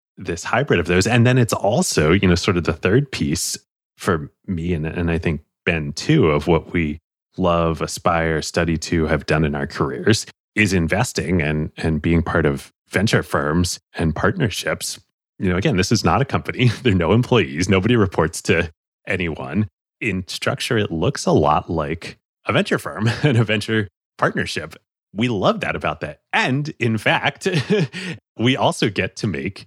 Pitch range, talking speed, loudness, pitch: 80-115 Hz, 180 wpm, -20 LUFS, 90 Hz